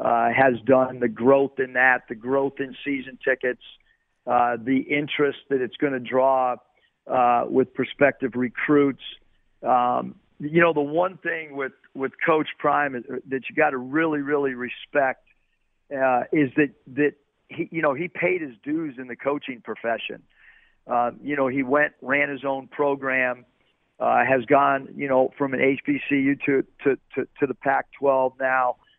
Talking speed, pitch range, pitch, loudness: 170 wpm, 130-145 Hz, 135 Hz, -23 LUFS